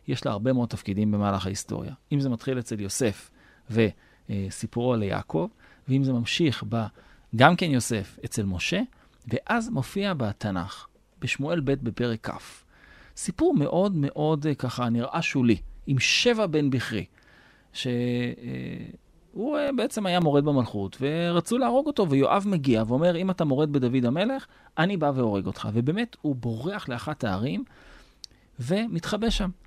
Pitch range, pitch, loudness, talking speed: 110-170 Hz, 130 Hz, -26 LUFS, 135 wpm